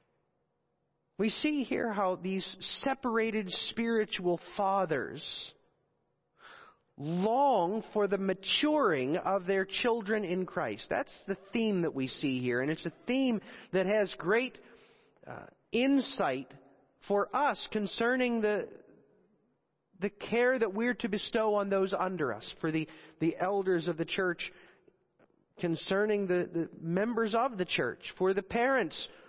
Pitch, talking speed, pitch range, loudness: 200 Hz, 130 wpm, 180-230 Hz, -32 LUFS